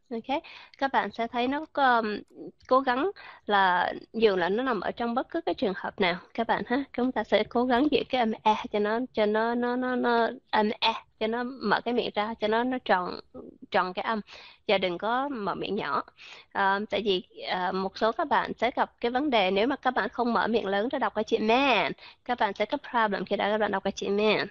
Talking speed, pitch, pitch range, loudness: 250 wpm, 225 Hz, 210-250 Hz, -27 LUFS